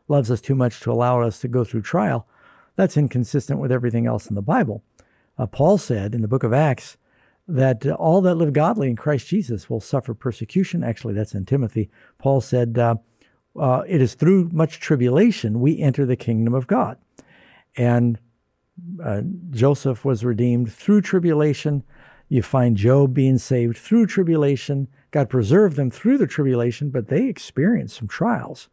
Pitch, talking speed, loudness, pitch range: 130 Hz, 175 wpm, -20 LUFS, 120-150 Hz